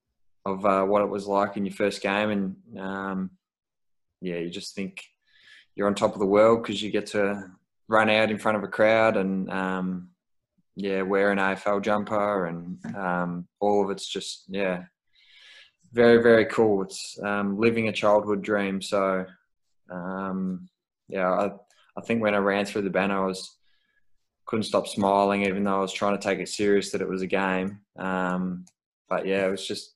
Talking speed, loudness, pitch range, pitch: 185 wpm, -25 LUFS, 95-105 Hz, 100 Hz